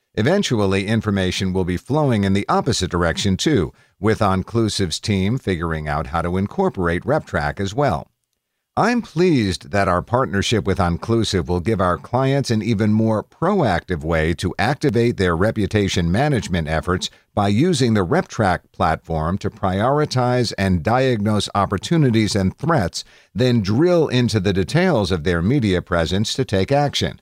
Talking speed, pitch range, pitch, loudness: 150 wpm, 90-125 Hz, 100 Hz, -19 LUFS